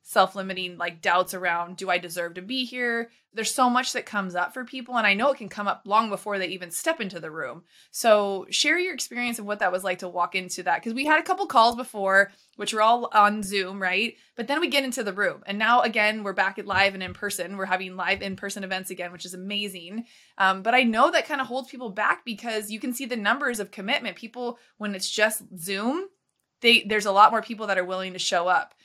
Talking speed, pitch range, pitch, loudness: 250 wpm, 185-240 Hz, 205 Hz, -24 LUFS